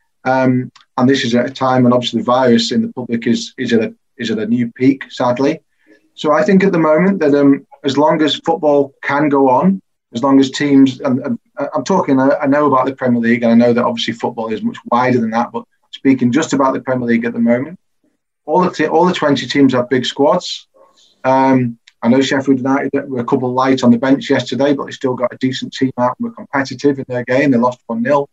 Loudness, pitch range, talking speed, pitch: -14 LUFS, 125-145 Hz, 245 wpm, 135 Hz